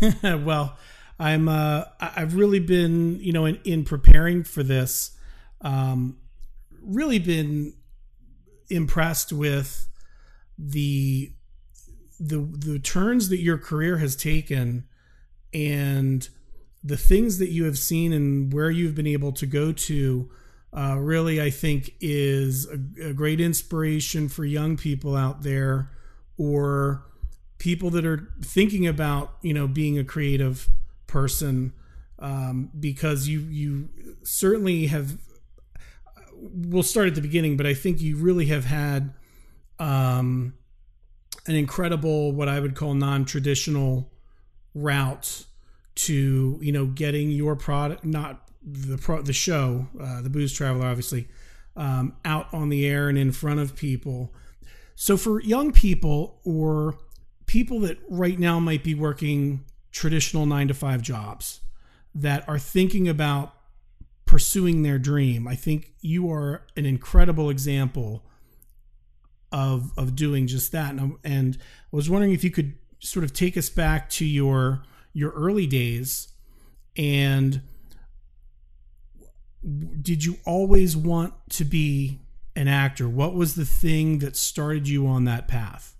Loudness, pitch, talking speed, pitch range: -24 LUFS, 145 Hz, 135 wpm, 130-160 Hz